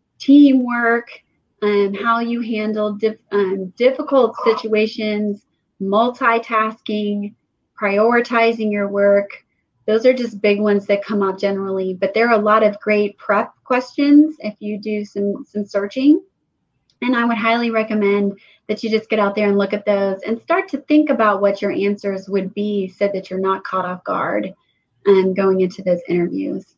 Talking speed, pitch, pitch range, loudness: 170 wpm, 210 Hz, 200-230 Hz, -18 LUFS